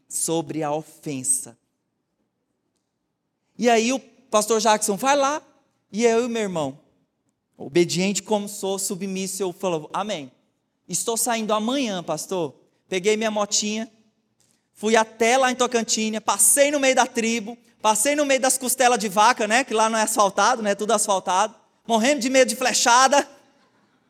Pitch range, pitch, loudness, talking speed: 195-245 Hz, 220 Hz, -21 LUFS, 150 wpm